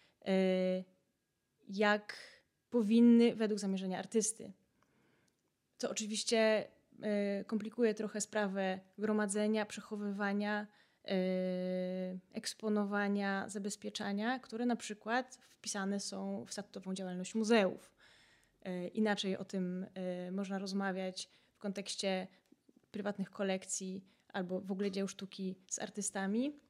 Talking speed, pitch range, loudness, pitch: 90 wpm, 190-215 Hz, -37 LUFS, 200 Hz